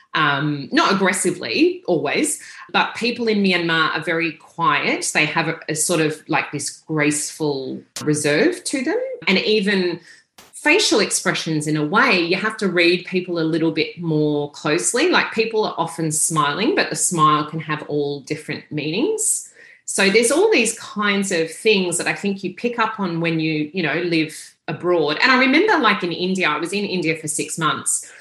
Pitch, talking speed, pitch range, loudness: 170 Hz, 185 wpm, 155-200 Hz, -19 LUFS